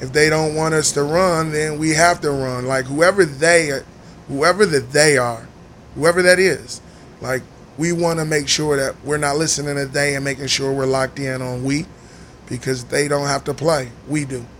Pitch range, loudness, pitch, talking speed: 135-160 Hz, -18 LUFS, 145 Hz, 205 wpm